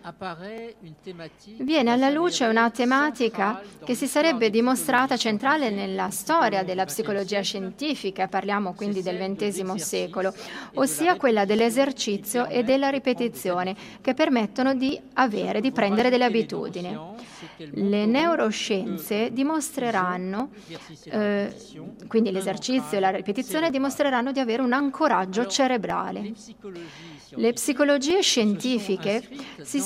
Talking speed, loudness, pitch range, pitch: 105 wpm, -24 LUFS, 195-265 Hz, 225 Hz